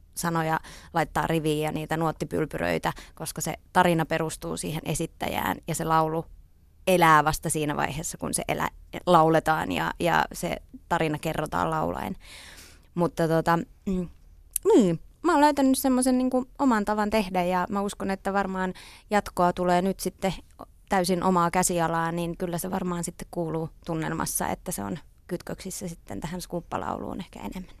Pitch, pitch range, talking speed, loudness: 175 Hz, 160-190 Hz, 145 wpm, -26 LUFS